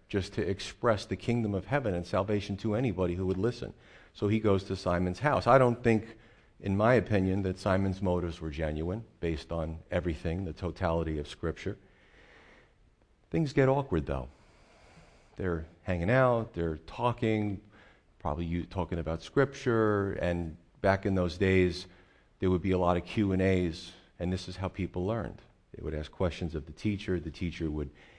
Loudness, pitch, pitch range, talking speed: -31 LUFS, 95 Hz, 85-105 Hz, 175 wpm